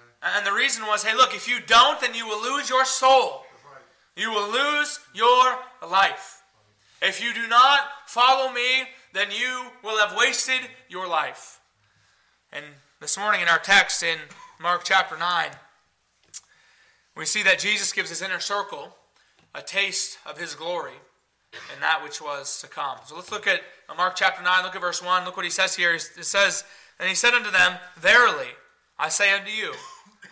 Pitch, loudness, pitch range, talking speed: 220 Hz, -22 LUFS, 190-260 Hz, 180 wpm